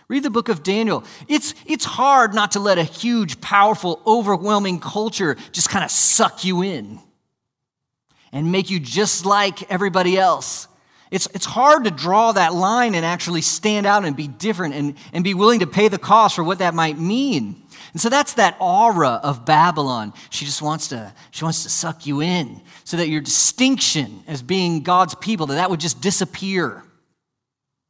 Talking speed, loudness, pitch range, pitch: 185 wpm, -18 LUFS, 155-210 Hz, 180 Hz